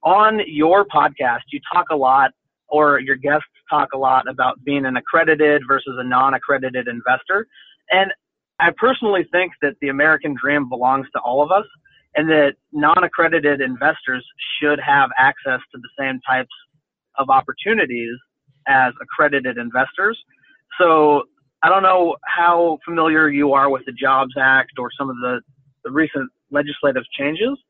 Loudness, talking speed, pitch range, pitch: -17 LUFS, 150 wpm, 135-165 Hz, 145 Hz